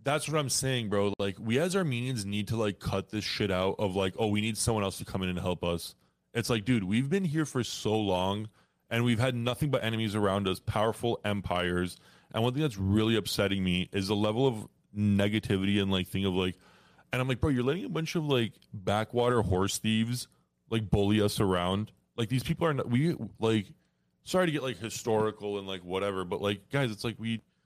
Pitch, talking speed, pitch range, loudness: 110 Hz, 220 wpm, 100-125 Hz, -30 LUFS